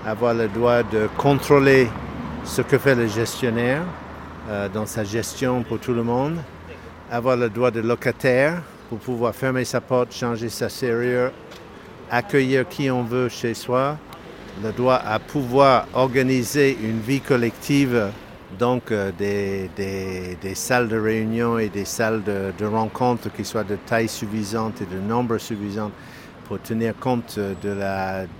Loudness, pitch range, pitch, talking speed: -22 LUFS, 105-125 Hz, 115 Hz, 155 wpm